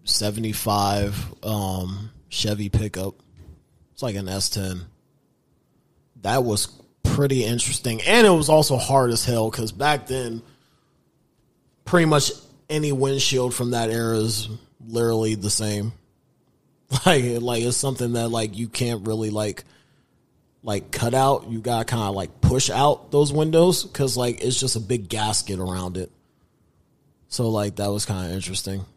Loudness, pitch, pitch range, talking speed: -22 LUFS, 115 Hz, 105-130 Hz, 150 wpm